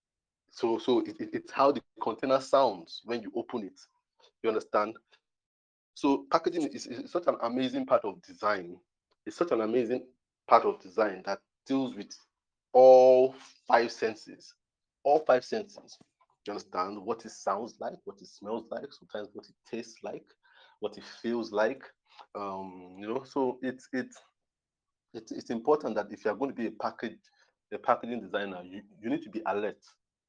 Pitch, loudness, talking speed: 130 Hz, -29 LUFS, 170 wpm